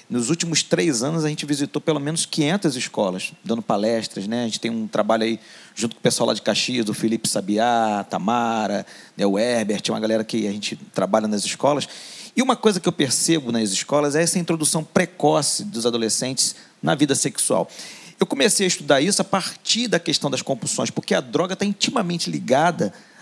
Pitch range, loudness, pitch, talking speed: 115-170 Hz, -21 LUFS, 145 Hz, 195 wpm